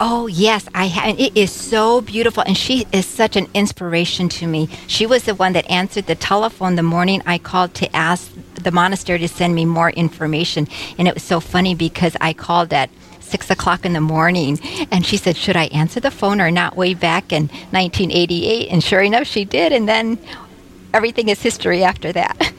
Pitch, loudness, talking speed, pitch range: 185 Hz, -17 LUFS, 205 wpm, 170-210 Hz